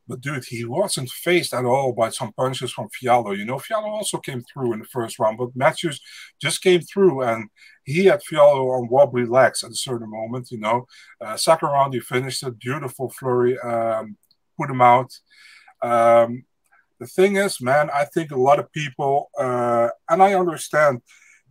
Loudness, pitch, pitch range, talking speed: -20 LUFS, 130 Hz, 120-165 Hz, 185 wpm